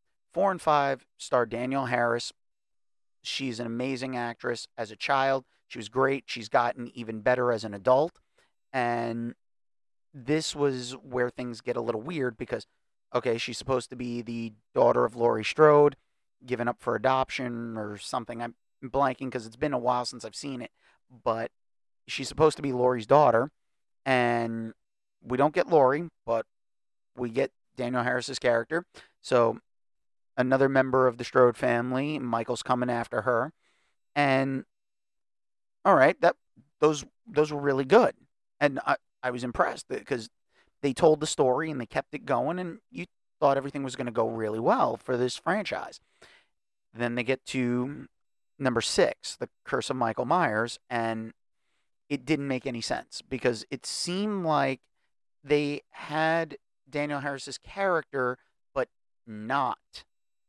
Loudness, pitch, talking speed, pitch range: -28 LUFS, 125 Hz, 155 wpm, 120-140 Hz